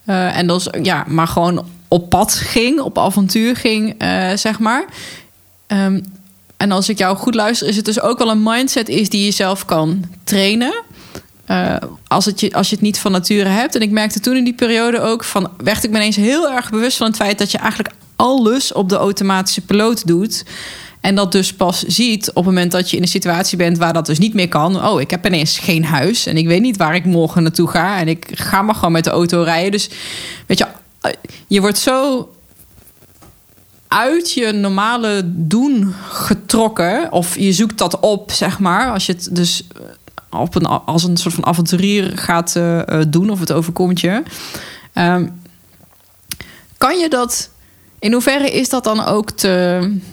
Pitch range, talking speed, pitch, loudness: 175-220 Hz, 200 wpm, 195 Hz, -15 LUFS